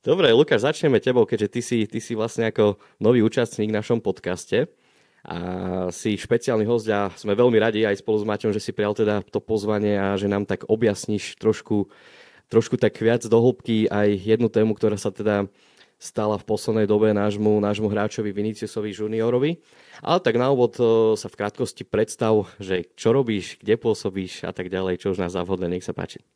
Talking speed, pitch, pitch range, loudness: 190 wpm, 105 Hz, 100-115 Hz, -22 LUFS